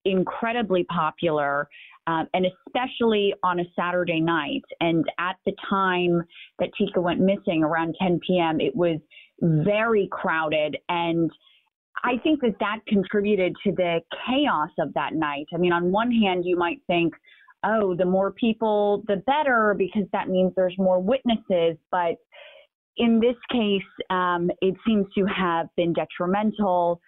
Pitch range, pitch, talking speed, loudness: 170-210 Hz, 185 Hz, 150 wpm, -24 LUFS